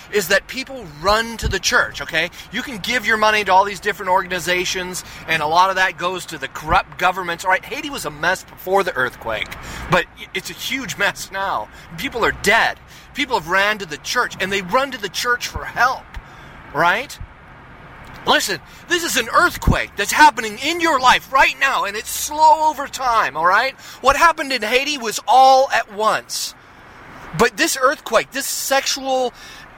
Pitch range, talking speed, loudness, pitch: 185-265 Hz, 185 wpm, -18 LUFS, 215 Hz